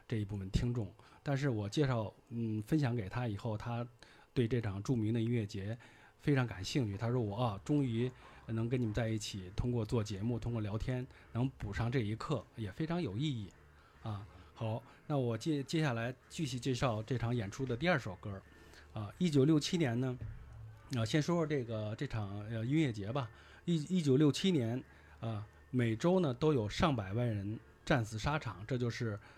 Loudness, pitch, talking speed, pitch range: -36 LUFS, 120 Hz, 270 characters per minute, 110-140 Hz